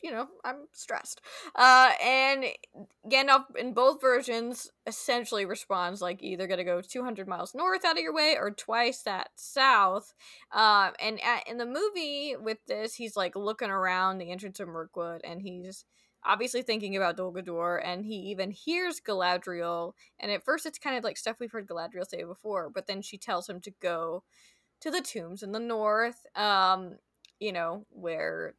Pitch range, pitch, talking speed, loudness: 185-250 Hz, 215 Hz, 175 wpm, -29 LUFS